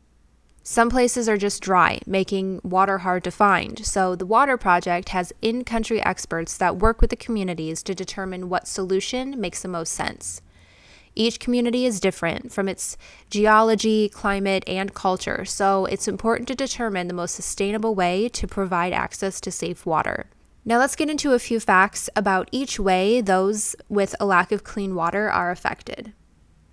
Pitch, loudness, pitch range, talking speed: 195 Hz, -22 LUFS, 180-225 Hz, 170 wpm